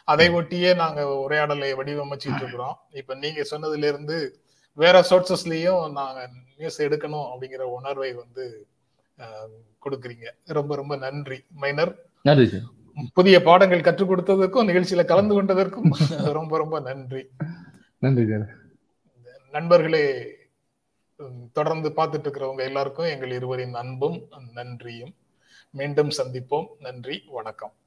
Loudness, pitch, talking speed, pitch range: -22 LUFS, 145 Hz, 100 wpm, 130-170 Hz